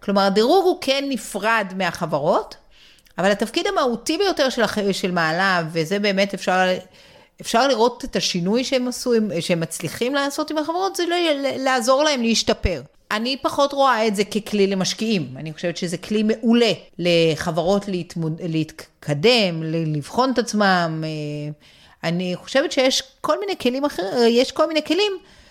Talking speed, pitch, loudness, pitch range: 145 wpm, 215 Hz, -20 LUFS, 175-265 Hz